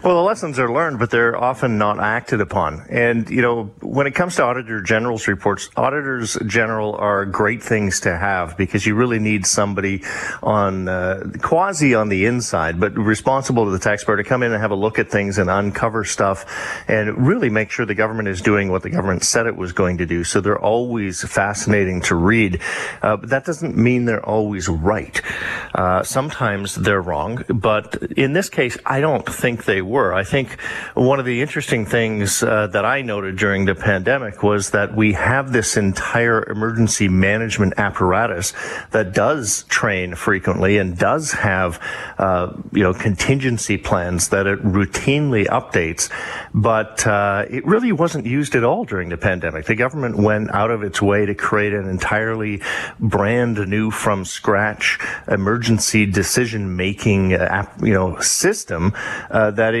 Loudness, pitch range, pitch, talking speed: -18 LUFS, 100-115 Hz, 105 Hz, 175 wpm